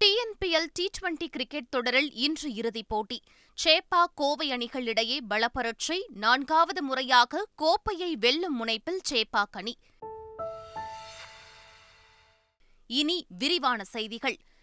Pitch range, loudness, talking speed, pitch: 230-335 Hz, -27 LUFS, 90 wpm, 270 Hz